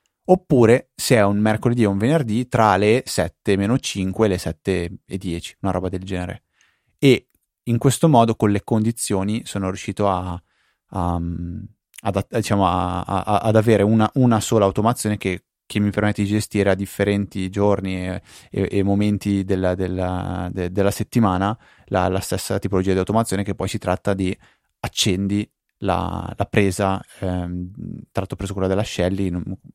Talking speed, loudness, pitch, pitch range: 160 wpm, -21 LUFS, 100 Hz, 95-110 Hz